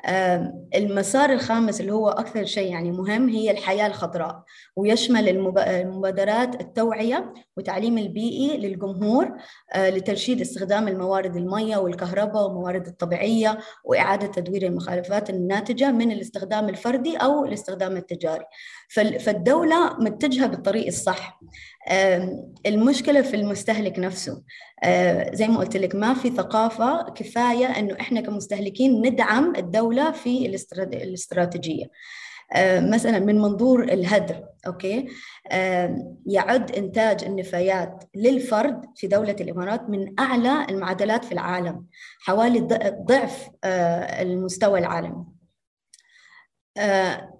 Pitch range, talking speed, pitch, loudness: 185-240 Hz, 100 wpm, 205 Hz, -23 LUFS